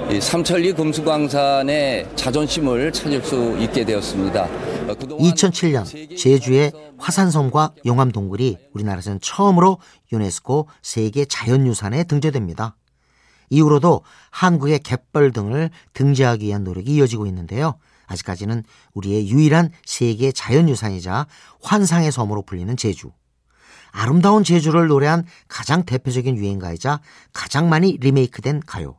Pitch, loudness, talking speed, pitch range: 135 Hz, -18 LUFS, 315 characters per minute, 110-155 Hz